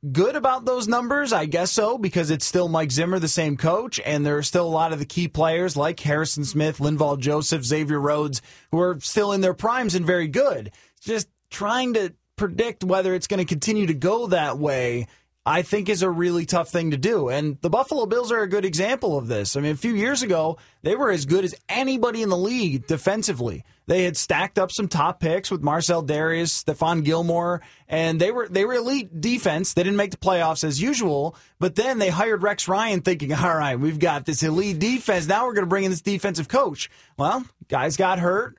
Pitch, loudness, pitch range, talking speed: 180 Hz, -23 LUFS, 155-205 Hz, 220 wpm